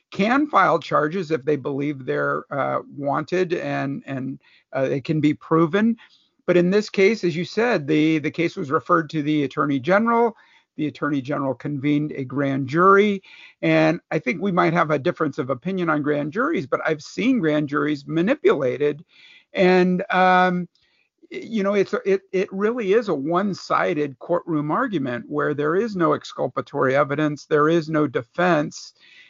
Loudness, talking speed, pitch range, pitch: -21 LUFS, 165 wpm, 150-190 Hz, 160 Hz